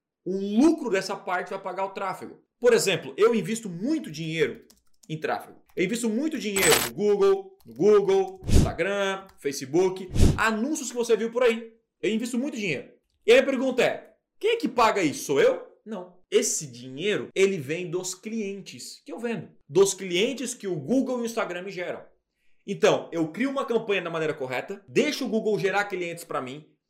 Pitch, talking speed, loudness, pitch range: 210 Hz, 185 wpm, -25 LUFS, 185-260 Hz